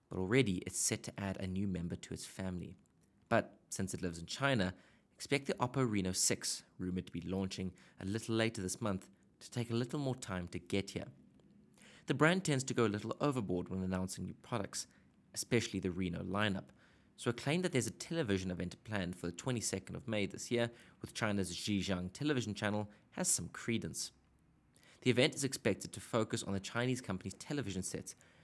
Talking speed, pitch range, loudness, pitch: 195 wpm, 95-120 Hz, -38 LUFS, 100 Hz